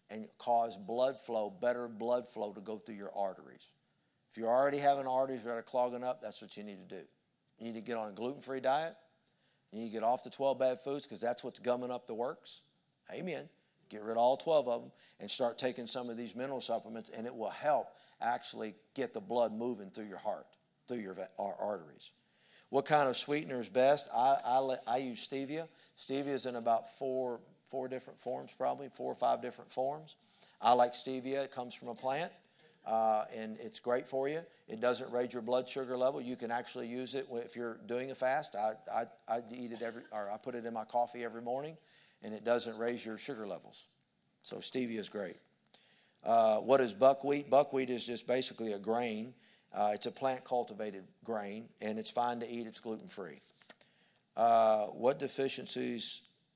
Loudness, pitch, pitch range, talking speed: -36 LUFS, 120 Hz, 115-130 Hz, 205 wpm